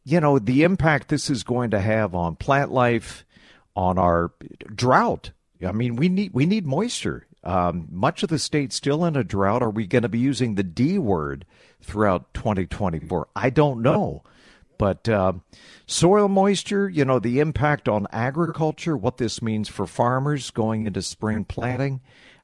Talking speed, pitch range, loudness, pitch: 170 wpm, 100-145 Hz, -22 LUFS, 120 Hz